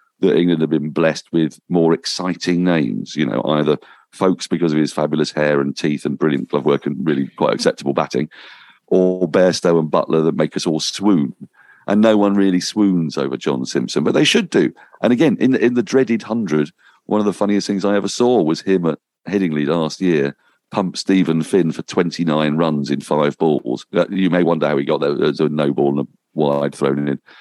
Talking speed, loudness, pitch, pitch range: 210 wpm, -18 LUFS, 80 Hz, 75-95 Hz